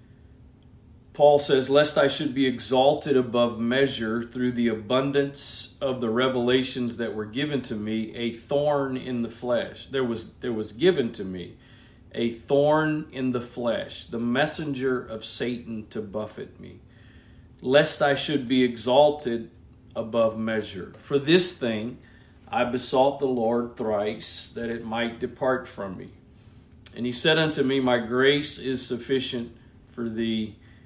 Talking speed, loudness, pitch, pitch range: 150 wpm, -25 LUFS, 125 Hz, 115-135 Hz